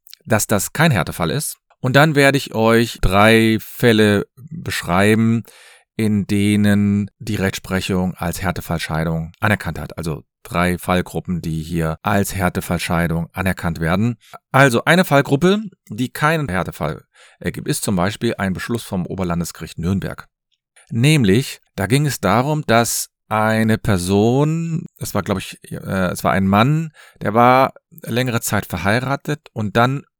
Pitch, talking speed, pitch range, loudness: 110 Hz, 135 wpm, 95-130 Hz, -18 LUFS